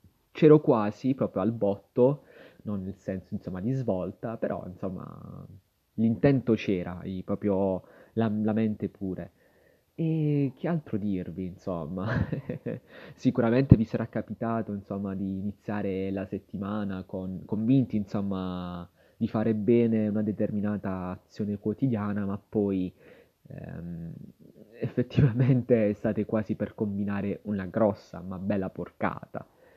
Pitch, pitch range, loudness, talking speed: 105 Hz, 95-115 Hz, -29 LUFS, 115 wpm